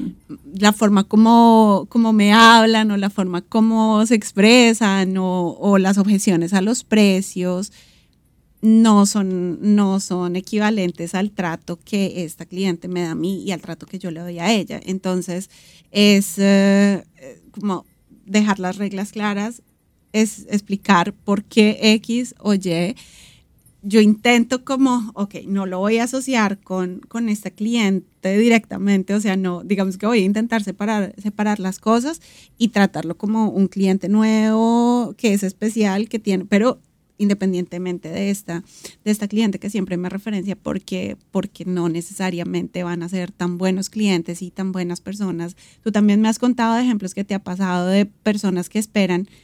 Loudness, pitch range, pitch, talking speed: -18 LUFS, 185-215 Hz, 200 Hz, 165 wpm